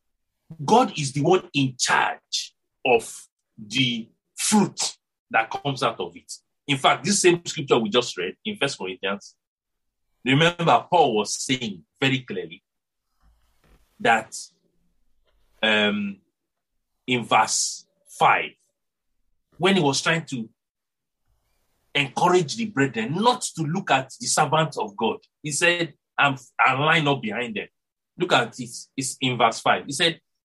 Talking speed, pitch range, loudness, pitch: 135 wpm, 125-165 Hz, -22 LUFS, 140 Hz